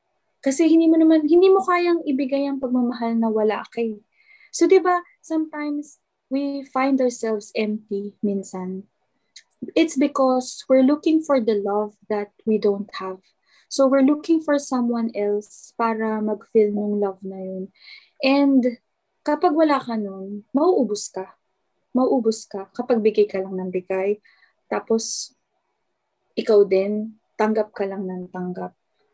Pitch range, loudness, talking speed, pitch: 205-280 Hz, -21 LUFS, 140 wpm, 230 Hz